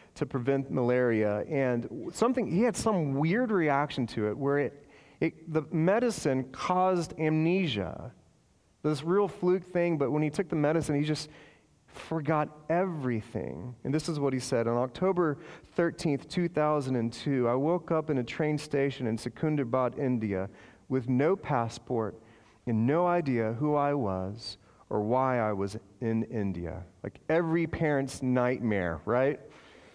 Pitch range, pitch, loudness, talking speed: 120-160 Hz, 140 Hz, -30 LUFS, 145 wpm